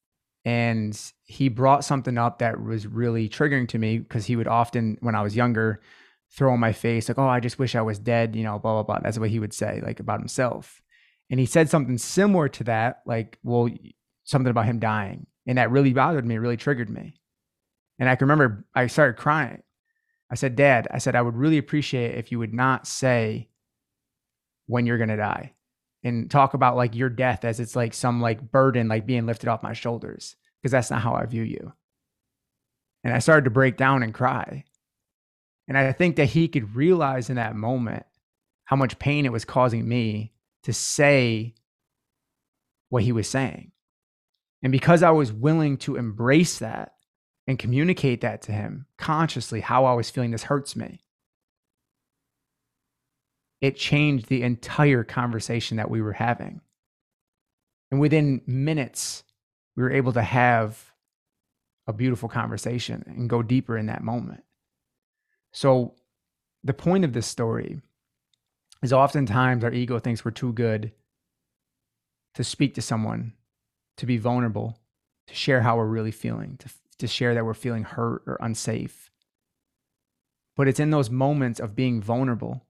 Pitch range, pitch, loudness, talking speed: 115-135 Hz, 120 Hz, -24 LUFS, 175 wpm